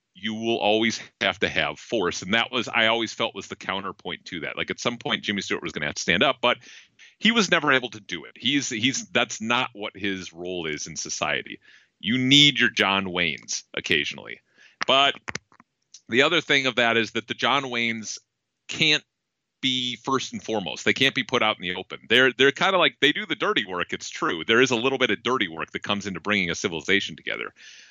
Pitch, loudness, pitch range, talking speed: 115 Hz, -23 LUFS, 105-130 Hz, 230 wpm